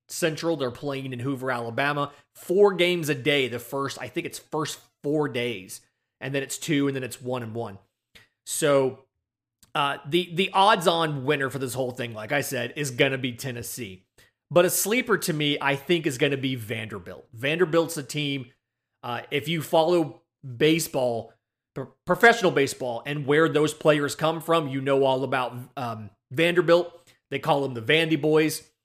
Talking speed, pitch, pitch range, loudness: 185 wpm, 140 Hz, 125-160 Hz, -25 LUFS